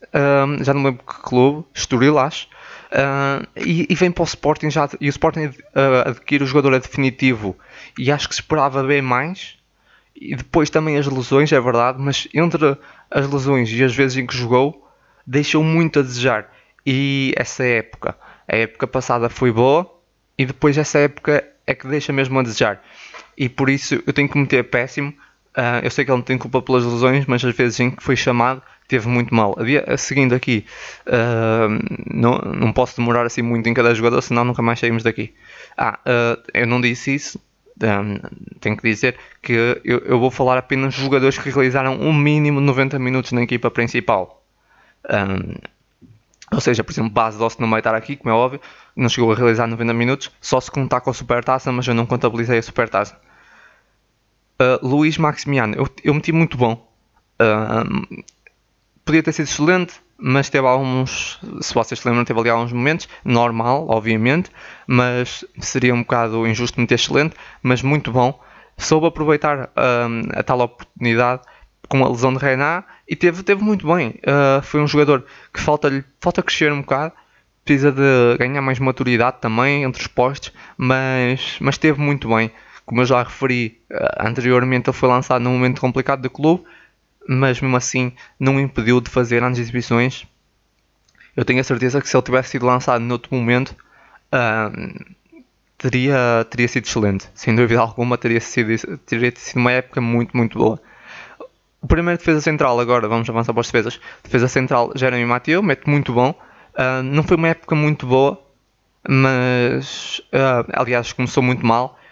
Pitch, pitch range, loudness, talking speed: 130 Hz, 120-140 Hz, -18 LUFS, 180 wpm